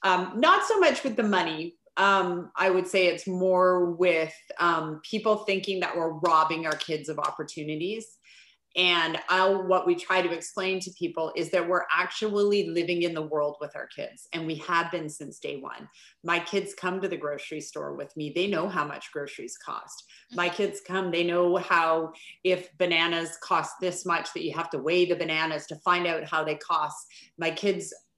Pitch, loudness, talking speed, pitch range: 175 Hz, -27 LUFS, 195 wpm, 165-190 Hz